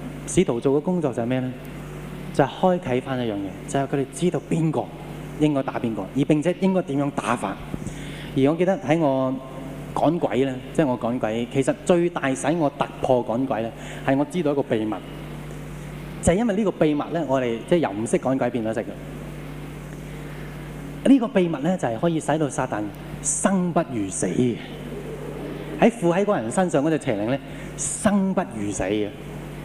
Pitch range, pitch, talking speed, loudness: 130-160 Hz, 145 Hz, 270 characters per minute, -23 LUFS